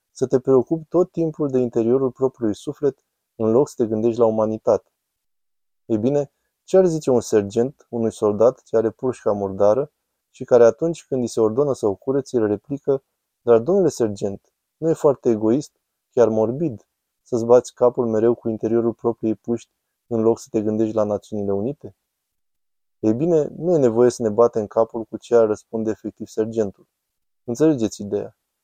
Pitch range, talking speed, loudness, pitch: 110-130 Hz, 175 wpm, -20 LUFS, 115 Hz